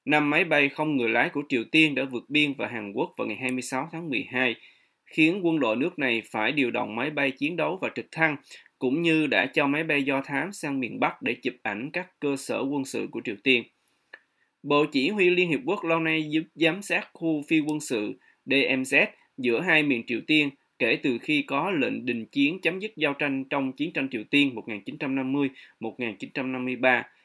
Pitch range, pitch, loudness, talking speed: 130-160 Hz, 145 Hz, -25 LUFS, 210 wpm